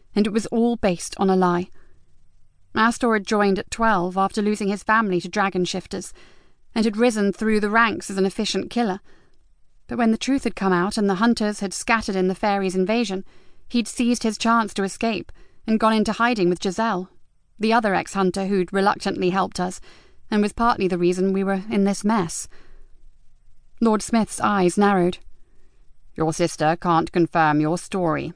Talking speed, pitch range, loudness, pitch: 180 wpm, 185-225 Hz, -21 LUFS, 200 Hz